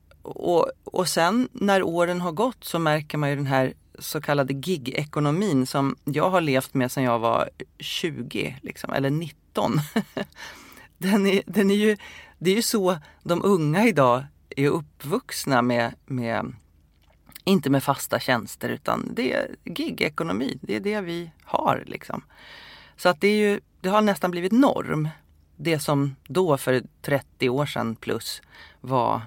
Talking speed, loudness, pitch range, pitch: 160 wpm, -24 LUFS, 135-195 Hz, 155 Hz